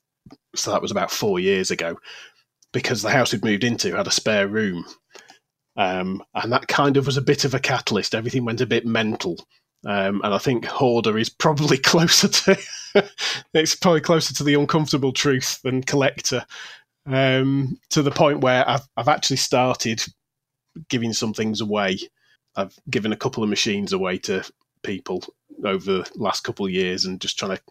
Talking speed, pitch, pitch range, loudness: 180 wpm, 135 Hz, 115-150 Hz, -21 LUFS